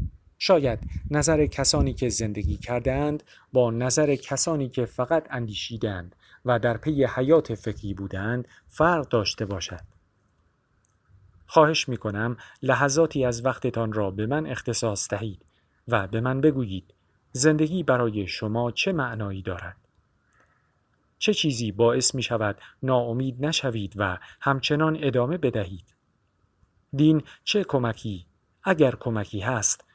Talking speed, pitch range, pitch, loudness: 120 wpm, 100-135 Hz, 120 Hz, -25 LUFS